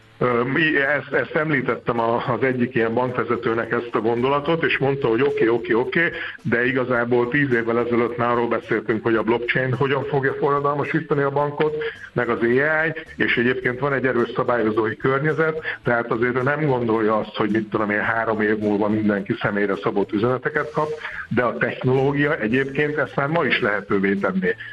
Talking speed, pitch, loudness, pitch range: 180 wpm, 125 Hz, -21 LUFS, 115-145 Hz